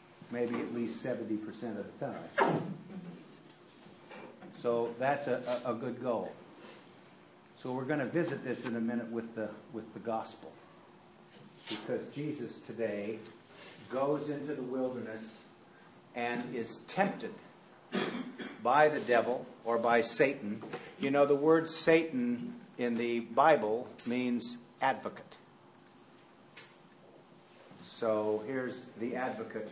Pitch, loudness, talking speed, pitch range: 125 Hz, -34 LUFS, 115 wpm, 115-150 Hz